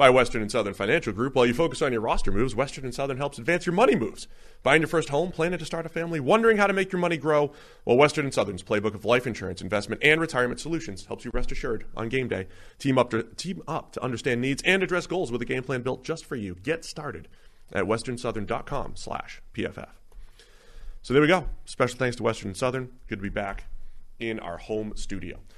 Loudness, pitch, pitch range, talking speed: -26 LUFS, 125 Hz, 110-160 Hz, 230 wpm